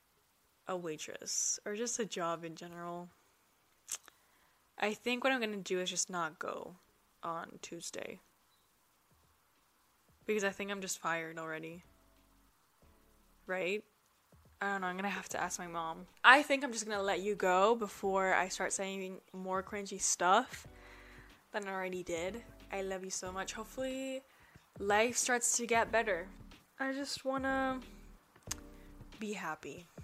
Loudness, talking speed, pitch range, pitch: -35 LUFS, 145 wpm, 180-225 Hz, 195 Hz